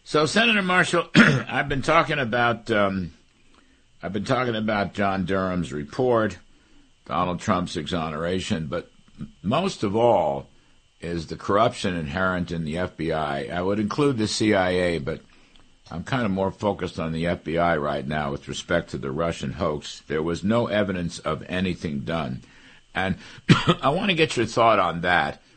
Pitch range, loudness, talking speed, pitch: 85-115 Hz, -24 LUFS, 155 wpm, 95 Hz